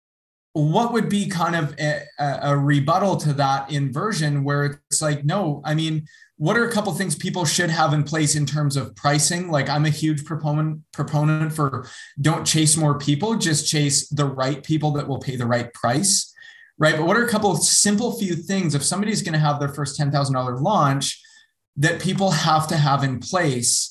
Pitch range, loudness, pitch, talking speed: 145-175 Hz, -21 LUFS, 155 Hz, 200 wpm